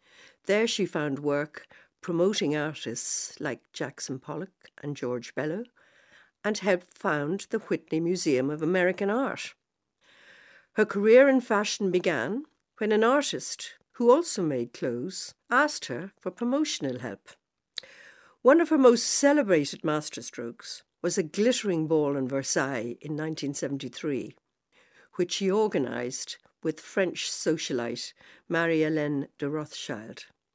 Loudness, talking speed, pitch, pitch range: -27 LUFS, 120 wpm, 180 Hz, 150-225 Hz